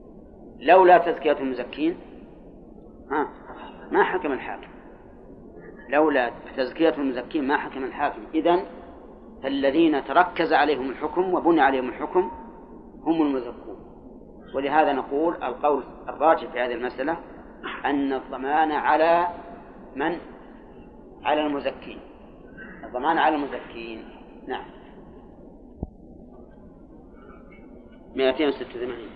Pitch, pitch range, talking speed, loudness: 145 Hz, 130-165 Hz, 90 wpm, -23 LUFS